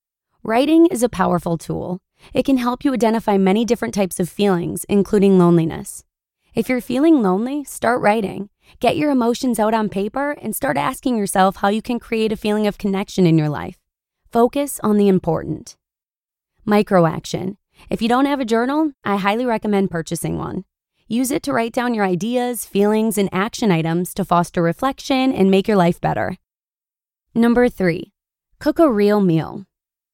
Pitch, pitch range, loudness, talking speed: 210 Hz, 185-245 Hz, -18 LUFS, 170 wpm